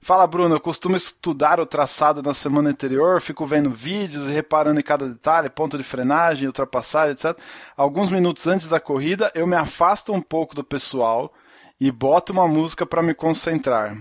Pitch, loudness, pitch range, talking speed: 155 Hz, -20 LUFS, 145-170 Hz, 180 wpm